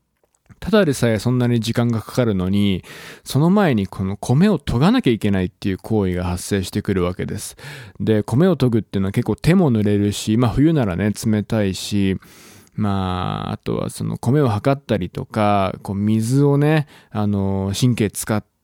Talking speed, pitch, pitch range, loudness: 345 characters per minute, 110 Hz, 100-130 Hz, -19 LUFS